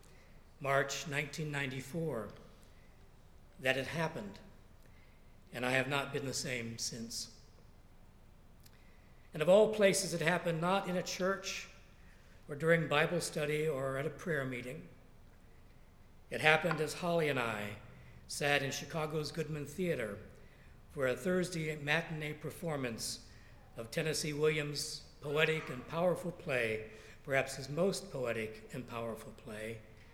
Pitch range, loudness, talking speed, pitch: 120-165 Hz, -35 LUFS, 125 wpm, 145 Hz